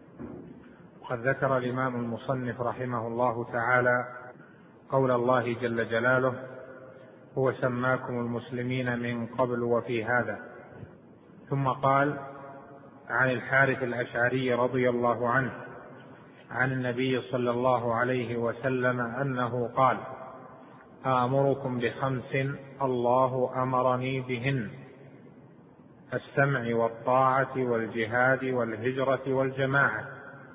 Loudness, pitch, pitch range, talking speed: -28 LUFS, 125 Hz, 120-130 Hz, 85 wpm